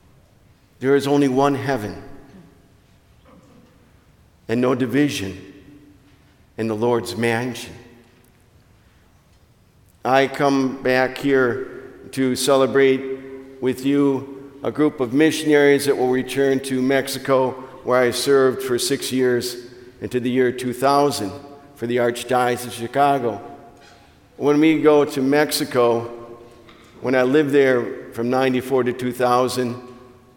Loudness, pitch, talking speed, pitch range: -19 LUFS, 130 Hz, 115 wpm, 120-140 Hz